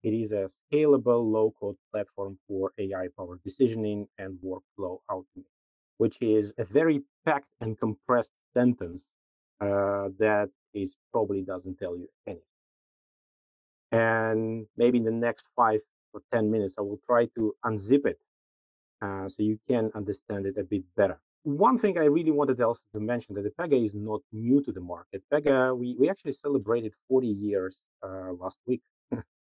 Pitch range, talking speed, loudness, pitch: 100-125 Hz, 160 wpm, -28 LUFS, 110 Hz